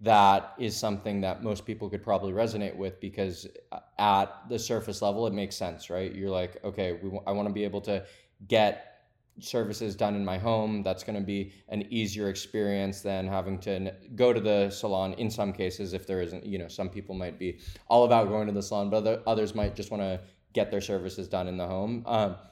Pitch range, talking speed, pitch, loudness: 95-110 Hz, 215 wpm, 100 Hz, -30 LUFS